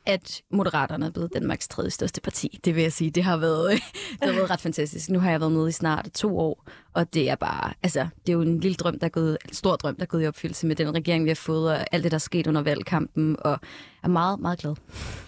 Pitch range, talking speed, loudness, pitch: 155-175 Hz, 275 wpm, -26 LUFS, 165 Hz